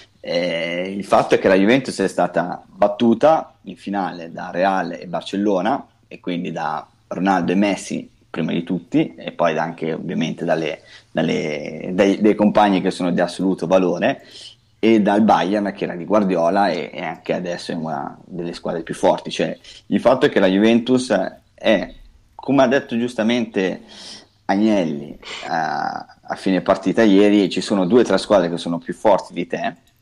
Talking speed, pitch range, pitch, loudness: 165 wpm, 90-110 Hz, 100 Hz, -19 LUFS